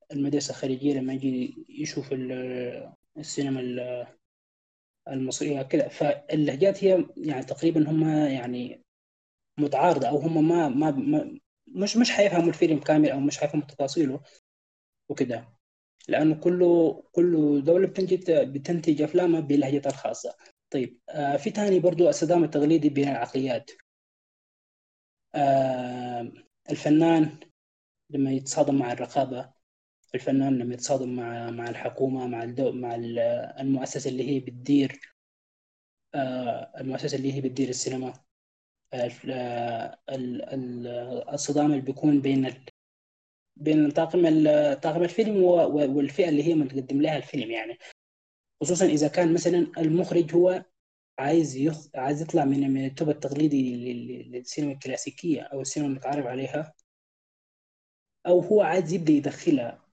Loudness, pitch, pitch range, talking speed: -26 LUFS, 140 Hz, 130-160 Hz, 110 wpm